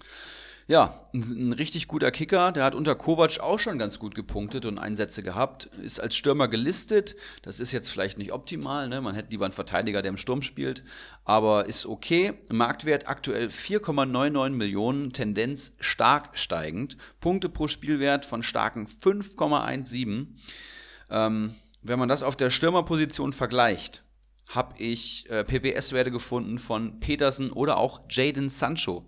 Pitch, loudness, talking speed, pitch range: 125 Hz, -26 LUFS, 150 wpm, 110-145 Hz